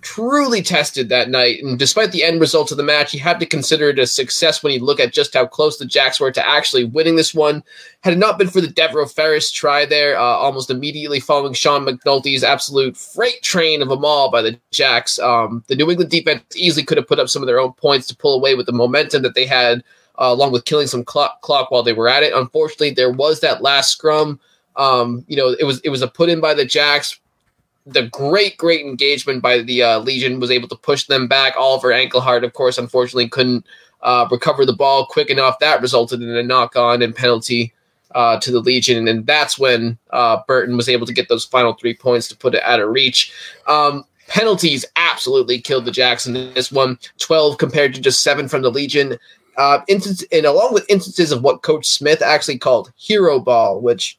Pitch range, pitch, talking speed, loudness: 125-155 Hz, 140 Hz, 225 wpm, -15 LUFS